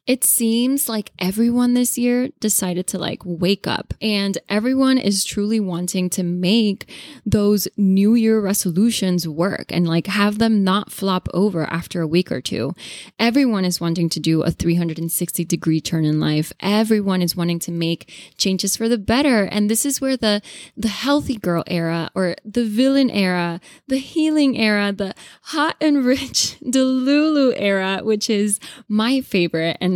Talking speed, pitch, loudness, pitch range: 170 wpm, 205 Hz, -19 LUFS, 175-240 Hz